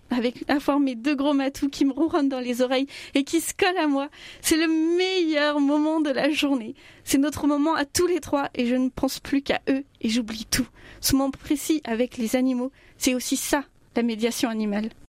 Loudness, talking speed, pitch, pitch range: -24 LUFS, 220 wpm, 280 Hz, 255-300 Hz